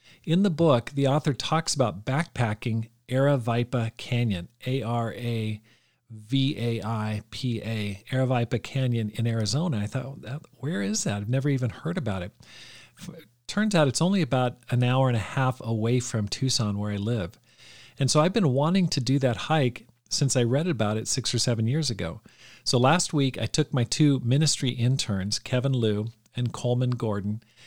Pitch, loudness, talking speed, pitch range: 125 Hz, -26 LUFS, 165 wpm, 115-140 Hz